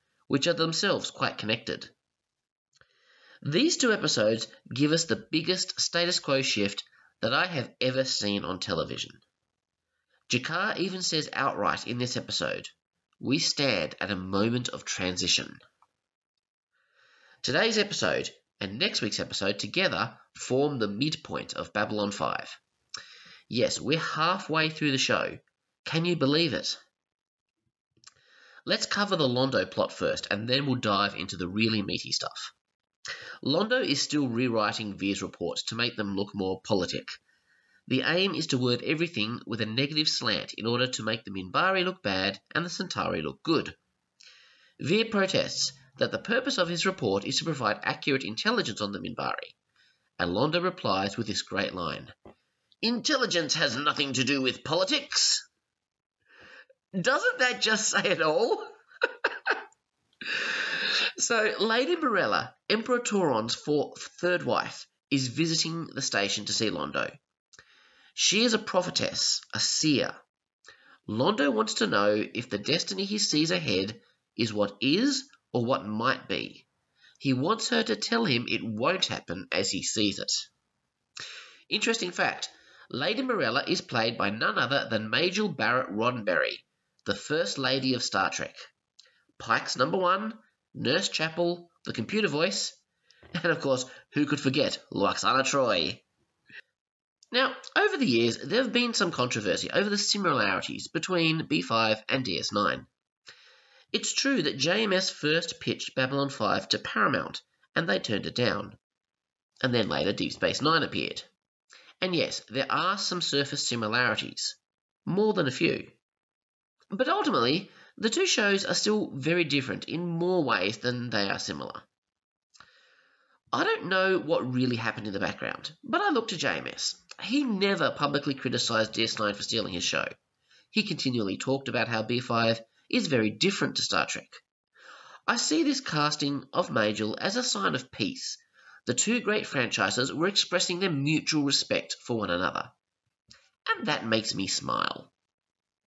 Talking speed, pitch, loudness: 150 wpm, 145 Hz, -28 LUFS